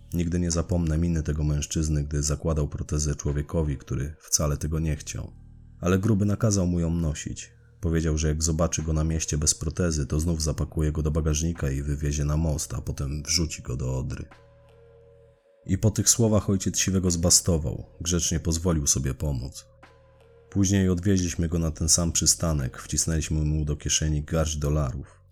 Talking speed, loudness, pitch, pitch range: 165 wpm, -25 LUFS, 80 Hz, 75-90 Hz